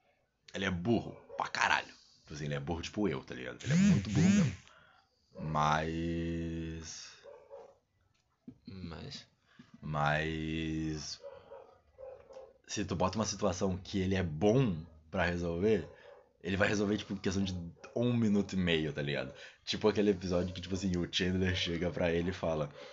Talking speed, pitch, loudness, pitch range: 150 wpm, 90 Hz, -33 LUFS, 80-105 Hz